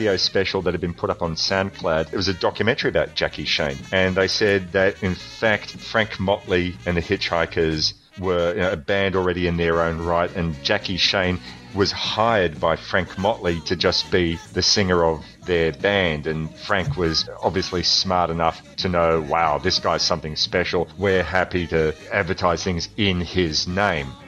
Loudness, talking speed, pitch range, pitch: -21 LUFS, 180 wpm, 85-95 Hz, 90 Hz